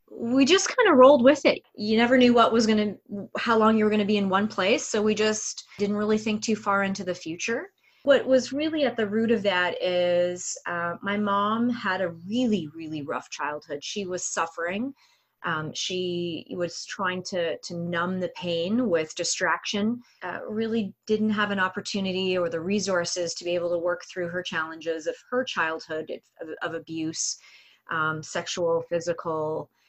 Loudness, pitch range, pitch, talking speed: -25 LUFS, 170-225 Hz, 195 Hz, 185 wpm